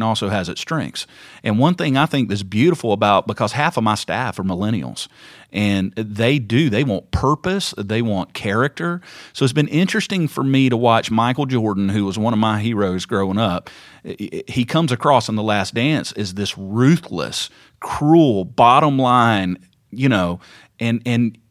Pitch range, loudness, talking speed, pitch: 100-135 Hz, -18 LUFS, 175 wpm, 115 Hz